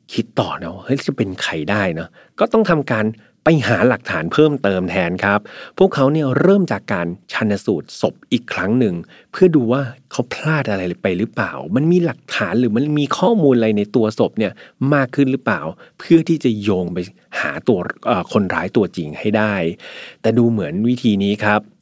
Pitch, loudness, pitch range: 120 Hz, -18 LUFS, 105-150 Hz